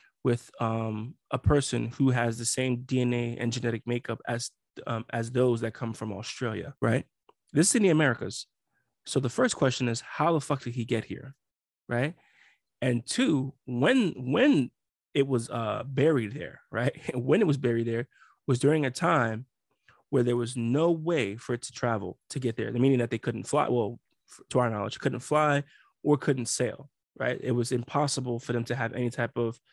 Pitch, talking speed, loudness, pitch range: 125 Hz, 195 wpm, -28 LUFS, 115-140 Hz